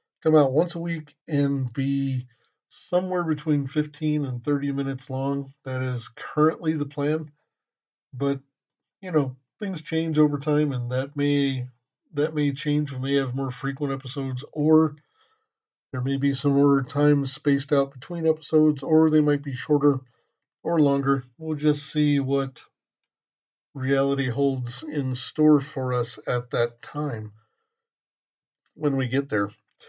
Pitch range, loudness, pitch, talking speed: 135-155 Hz, -25 LUFS, 140 Hz, 145 wpm